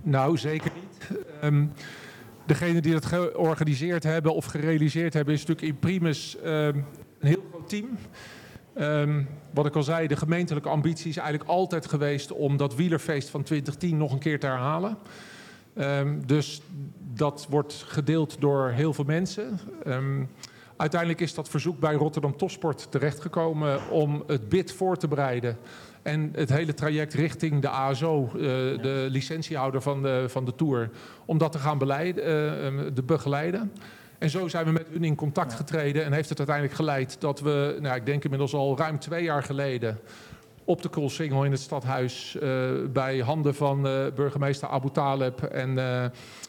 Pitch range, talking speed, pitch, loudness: 140-160 Hz, 170 wpm, 150 Hz, -27 LUFS